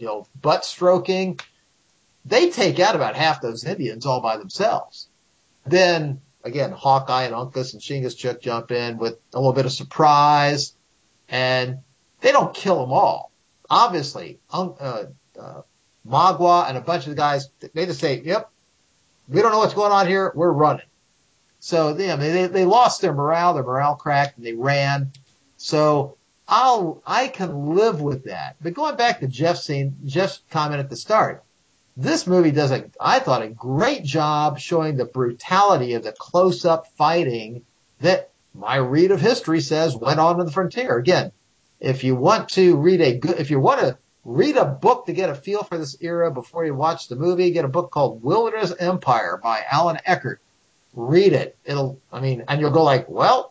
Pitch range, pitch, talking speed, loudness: 135-180 Hz, 150 Hz, 185 wpm, -20 LUFS